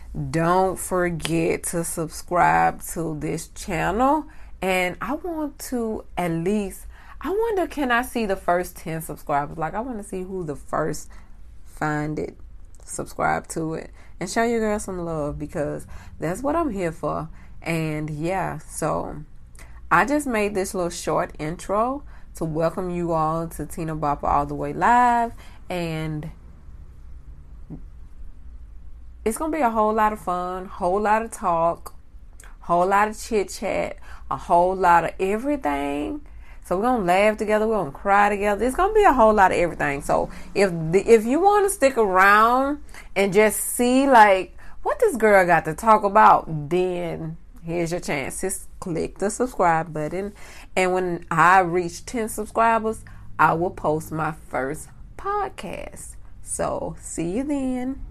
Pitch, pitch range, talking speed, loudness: 180 Hz, 155-215 Hz, 160 wpm, -22 LUFS